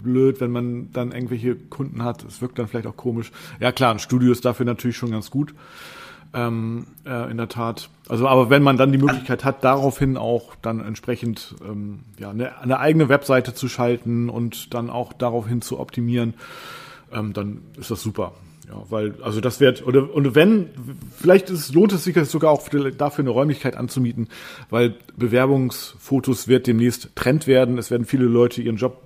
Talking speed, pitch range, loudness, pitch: 185 wpm, 120-135 Hz, -21 LUFS, 125 Hz